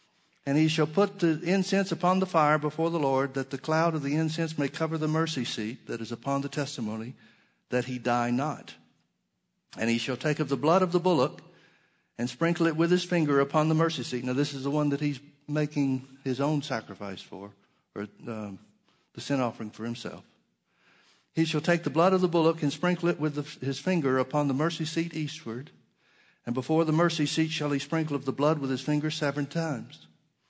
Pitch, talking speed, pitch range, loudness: 145 Hz, 210 wpm, 130-160 Hz, -28 LUFS